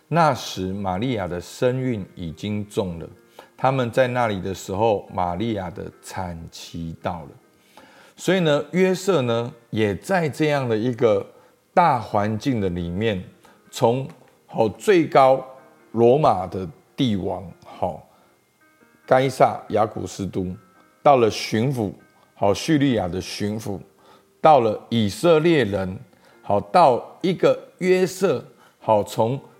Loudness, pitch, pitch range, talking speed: -21 LUFS, 115 Hz, 95-135 Hz, 180 characters per minute